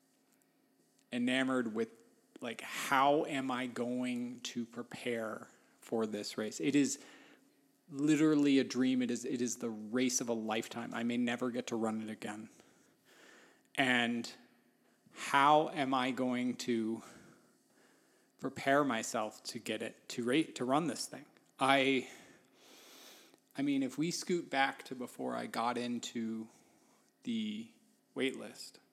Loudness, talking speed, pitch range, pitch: -35 LUFS, 135 wpm, 120-135 Hz, 125 Hz